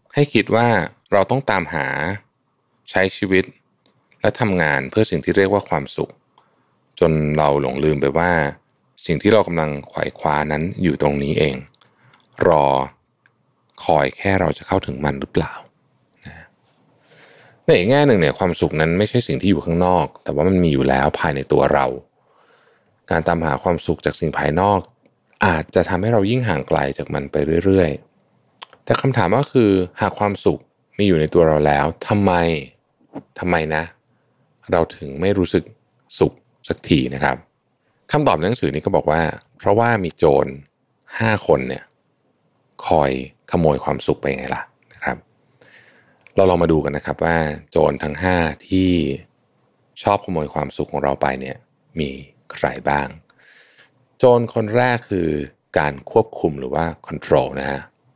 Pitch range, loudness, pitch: 75-100 Hz, -19 LUFS, 85 Hz